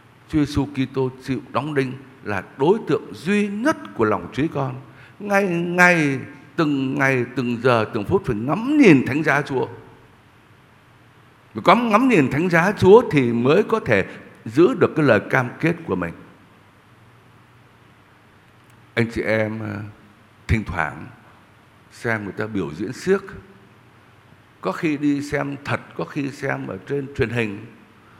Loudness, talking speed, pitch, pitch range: -20 LUFS, 150 wpm, 130 Hz, 110-145 Hz